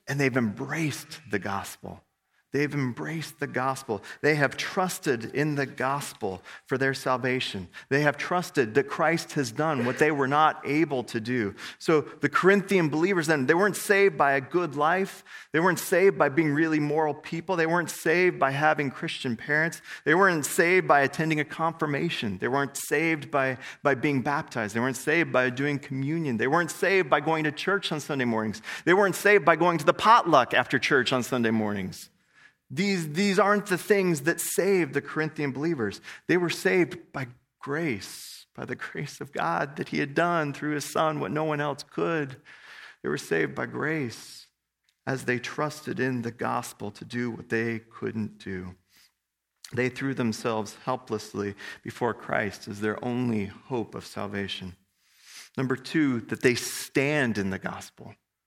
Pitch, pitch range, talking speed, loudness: 145 Hz, 125-165 Hz, 175 wpm, -26 LUFS